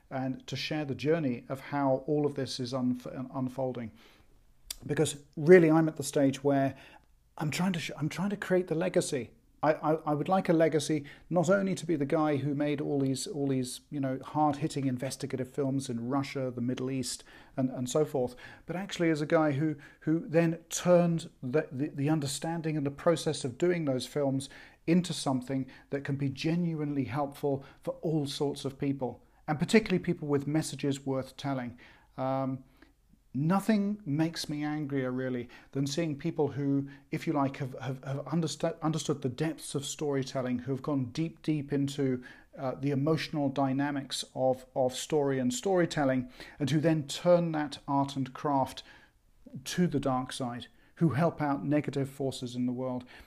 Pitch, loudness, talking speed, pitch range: 140 Hz, -31 LUFS, 180 wpm, 135-155 Hz